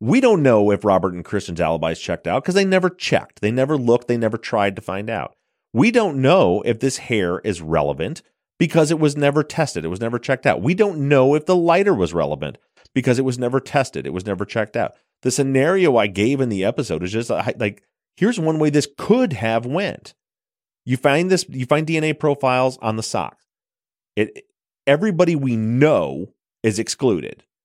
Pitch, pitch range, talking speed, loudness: 130 Hz, 110-155 Hz, 200 wpm, -19 LUFS